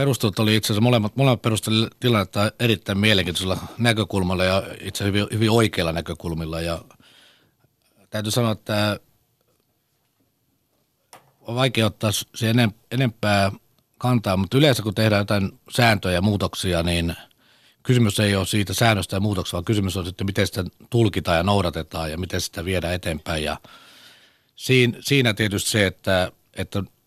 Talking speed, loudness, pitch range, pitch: 140 wpm, -22 LUFS, 95-115 Hz, 105 Hz